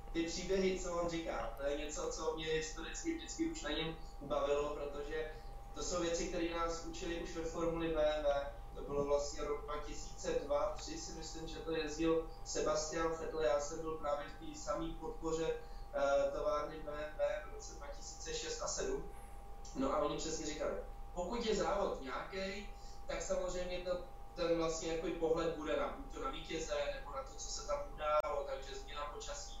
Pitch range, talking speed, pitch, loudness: 150-170 Hz, 175 wpm, 160 Hz, -40 LUFS